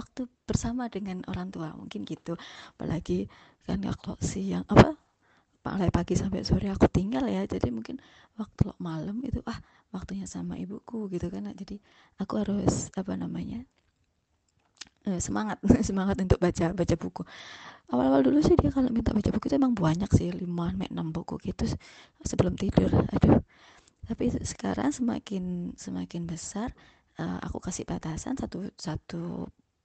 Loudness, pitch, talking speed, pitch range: -29 LUFS, 190 Hz, 155 wpm, 165-220 Hz